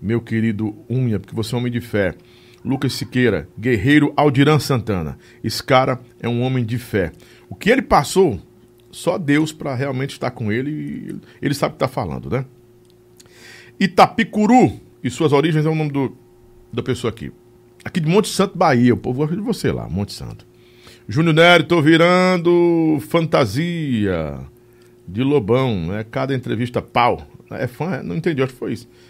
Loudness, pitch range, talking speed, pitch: -18 LUFS, 120-150 Hz, 175 wpm, 125 Hz